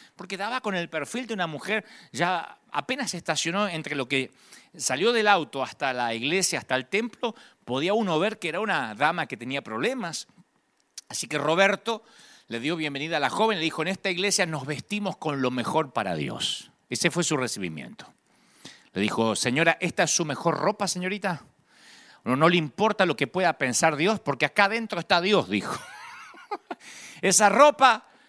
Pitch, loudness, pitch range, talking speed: 175 Hz, -25 LUFS, 150-210 Hz, 180 wpm